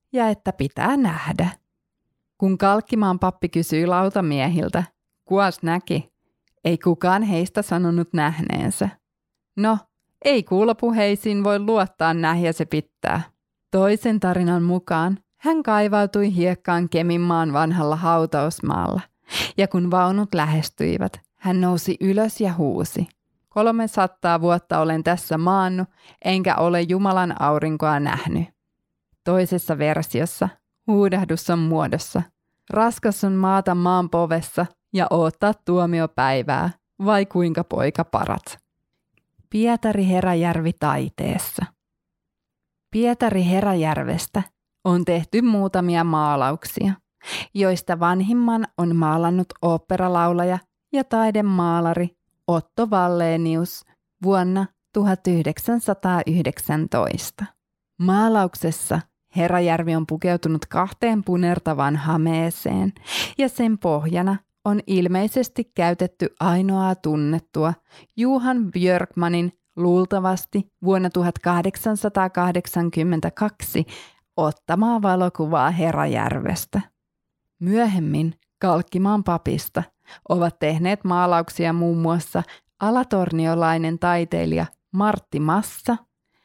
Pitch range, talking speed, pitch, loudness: 165-195 Hz, 85 wpm, 180 Hz, -21 LUFS